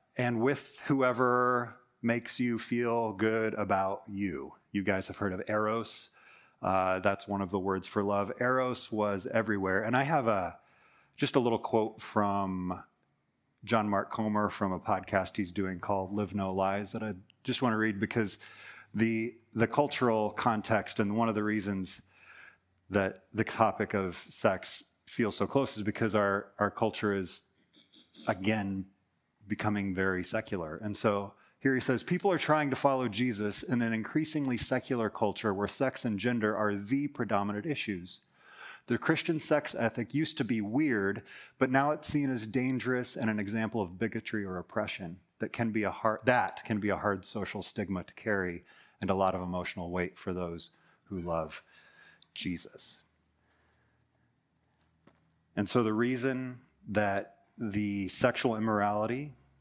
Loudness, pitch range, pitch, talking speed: -32 LUFS, 100-120 Hz, 110 Hz, 160 wpm